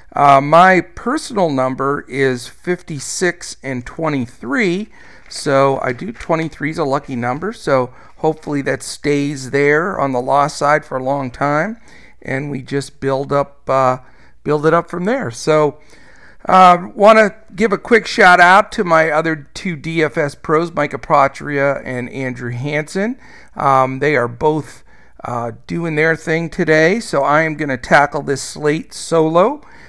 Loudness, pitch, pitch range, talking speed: -15 LUFS, 150 Hz, 135-170 Hz, 160 wpm